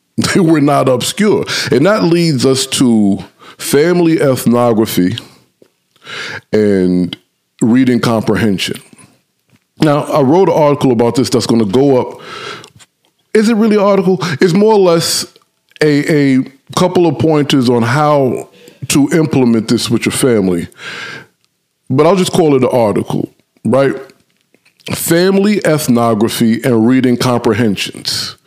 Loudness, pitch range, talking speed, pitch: -12 LUFS, 120-170 Hz, 130 wpm, 135 Hz